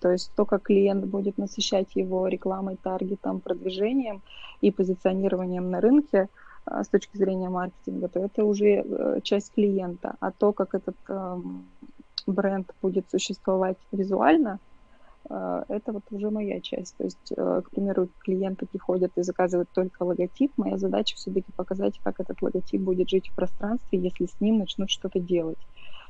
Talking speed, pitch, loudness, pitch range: 145 wpm, 190 Hz, -27 LUFS, 180-205 Hz